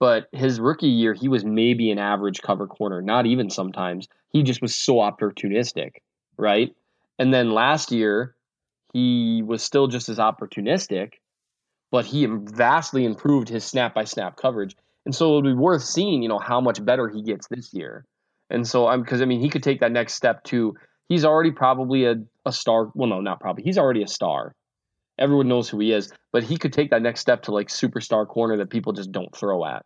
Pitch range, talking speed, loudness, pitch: 110-130 Hz, 210 wpm, -22 LUFS, 120 Hz